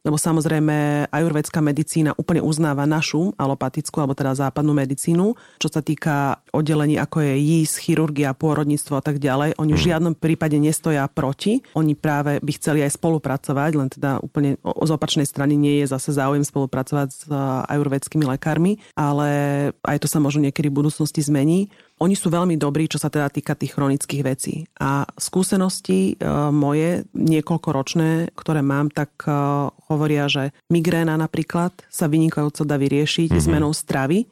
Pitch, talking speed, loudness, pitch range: 150 Hz, 155 wpm, -21 LUFS, 145-160 Hz